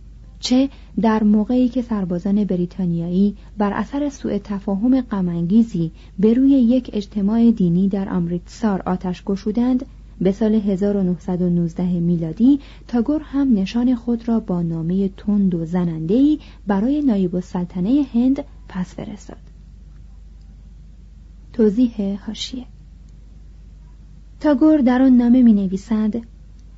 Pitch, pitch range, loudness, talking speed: 205 Hz, 180-240 Hz, -19 LUFS, 110 wpm